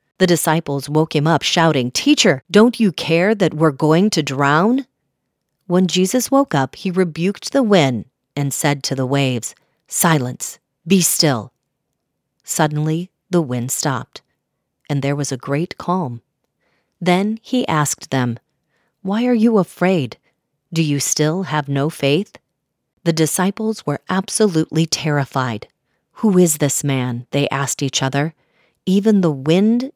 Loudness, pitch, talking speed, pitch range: -17 LUFS, 160 Hz, 140 wpm, 140-190 Hz